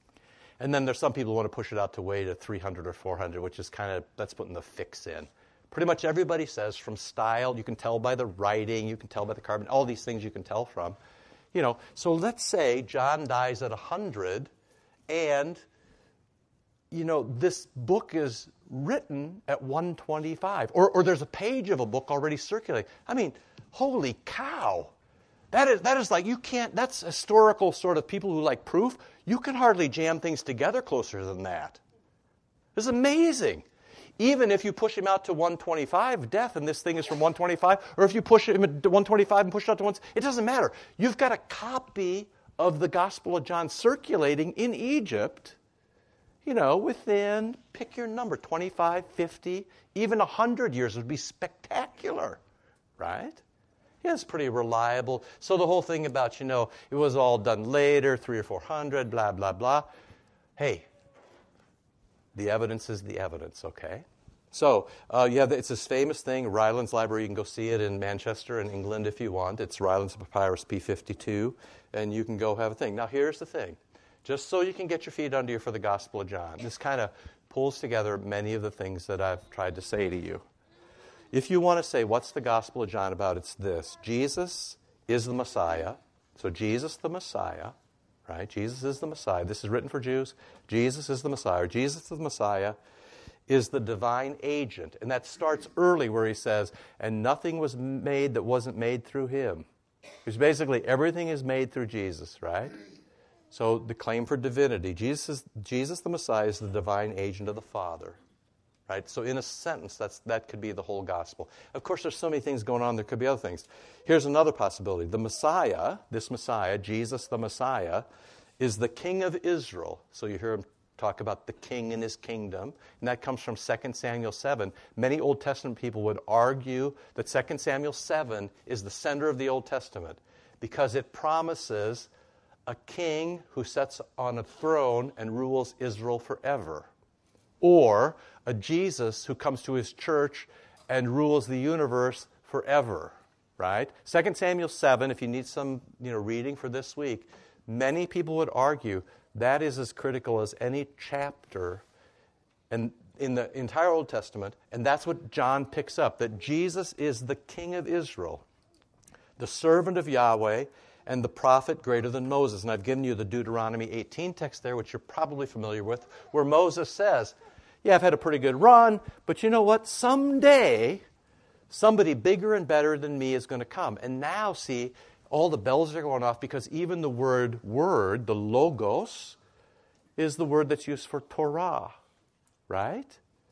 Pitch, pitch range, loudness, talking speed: 135 Hz, 115-165 Hz, -28 LUFS, 185 wpm